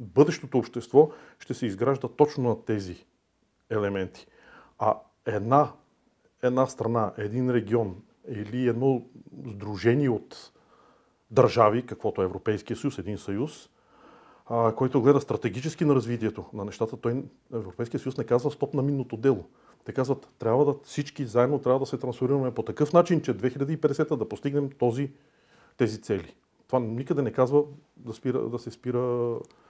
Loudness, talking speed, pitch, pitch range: -27 LUFS, 145 wpm, 125 Hz, 115-140 Hz